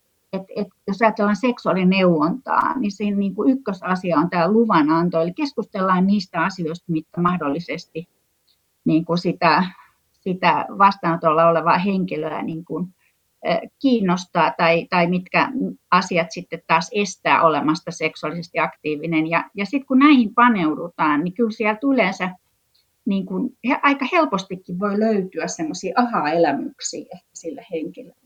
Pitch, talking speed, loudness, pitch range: 180 Hz, 125 wpm, -20 LUFS, 165-210 Hz